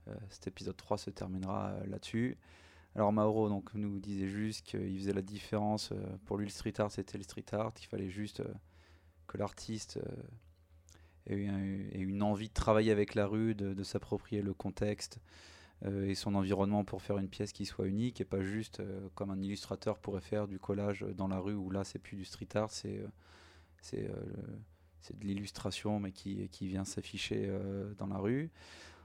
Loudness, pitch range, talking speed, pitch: -38 LUFS, 95-105 Hz, 195 wpm, 100 Hz